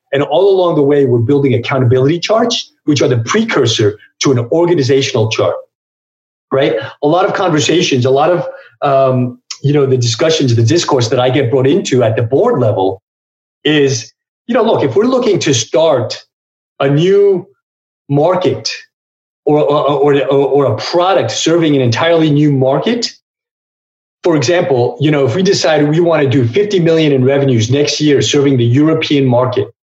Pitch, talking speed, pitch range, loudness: 140 Hz, 170 wpm, 130-170 Hz, -12 LUFS